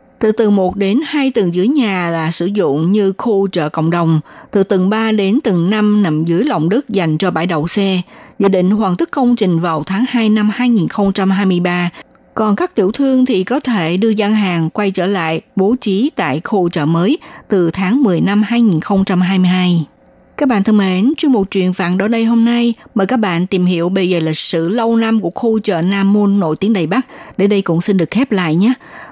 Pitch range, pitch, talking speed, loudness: 180-225 Hz, 200 Hz, 220 wpm, -14 LUFS